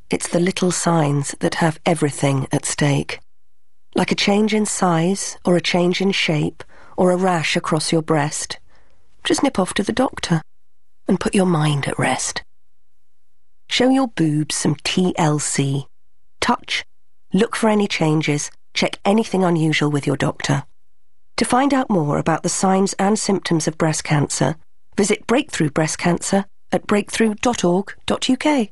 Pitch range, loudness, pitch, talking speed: 150-200 Hz, -19 LUFS, 175 Hz, 150 wpm